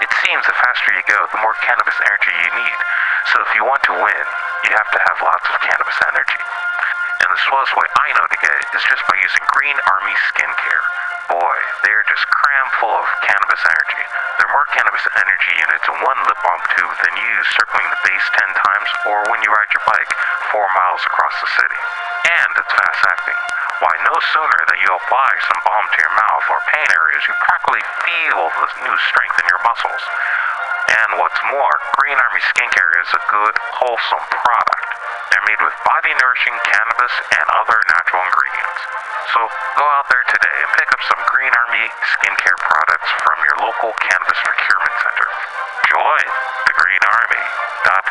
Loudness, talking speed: -14 LUFS, 190 wpm